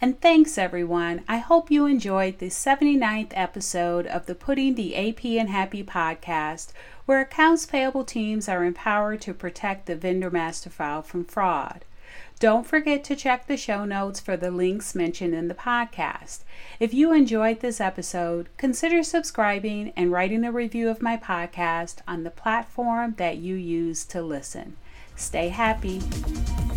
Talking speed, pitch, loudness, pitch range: 155 wpm, 200 Hz, -24 LUFS, 175-240 Hz